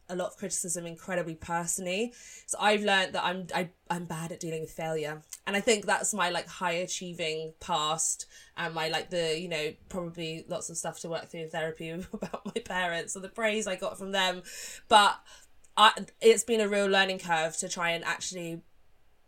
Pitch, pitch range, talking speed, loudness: 175 Hz, 165-195 Hz, 200 wpm, -29 LUFS